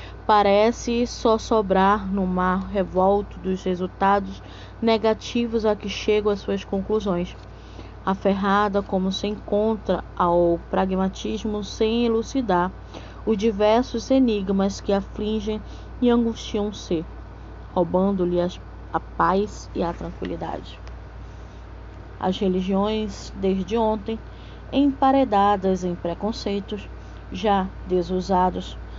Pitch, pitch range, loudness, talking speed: 200 Hz, 185-215 Hz, -23 LUFS, 95 wpm